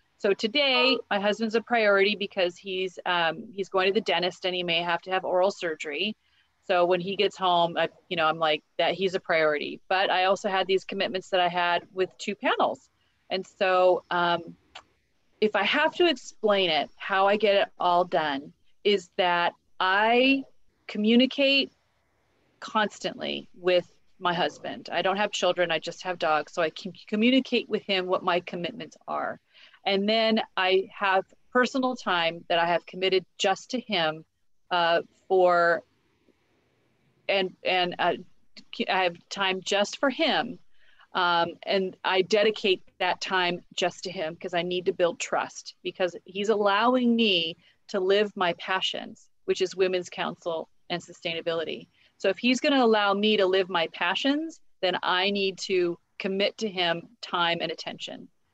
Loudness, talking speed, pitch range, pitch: -26 LUFS, 165 wpm, 175-210 Hz, 190 Hz